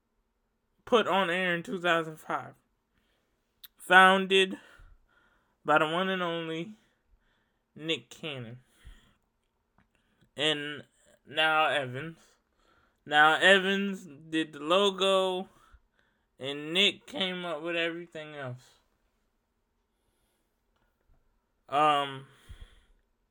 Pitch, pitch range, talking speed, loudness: 160 Hz, 135-185 Hz, 75 wpm, -27 LUFS